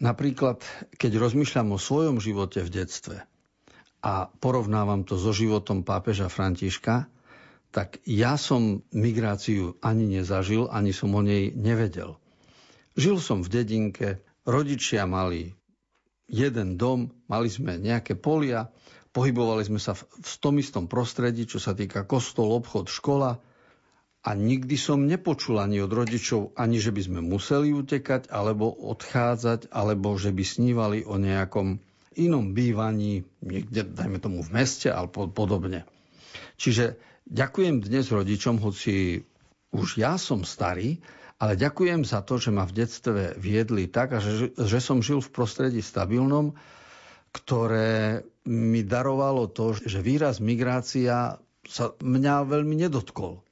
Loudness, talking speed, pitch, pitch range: -26 LUFS, 135 wpm, 115 Hz, 100-125 Hz